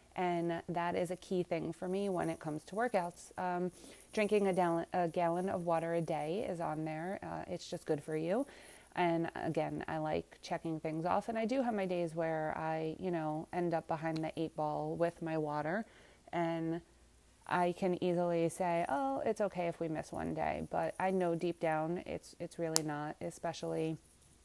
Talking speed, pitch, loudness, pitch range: 200 wpm, 170 Hz, -37 LUFS, 160-180 Hz